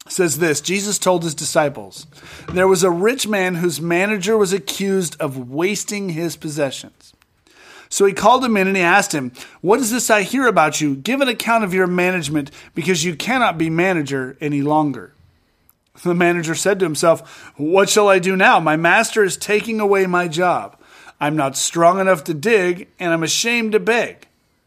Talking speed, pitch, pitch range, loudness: 185 wpm, 180 Hz, 160-200 Hz, -17 LUFS